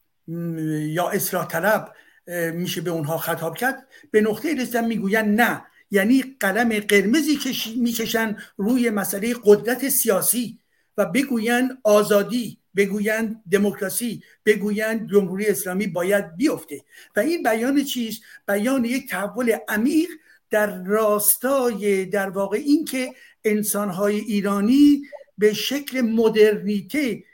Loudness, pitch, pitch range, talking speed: -21 LUFS, 215 Hz, 200-245 Hz, 110 wpm